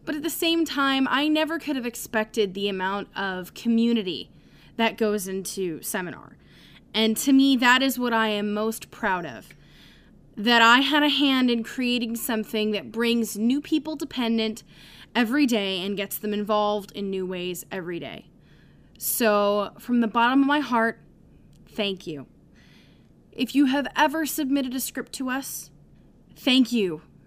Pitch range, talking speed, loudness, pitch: 210-270 Hz, 160 wpm, -24 LUFS, 230 Hz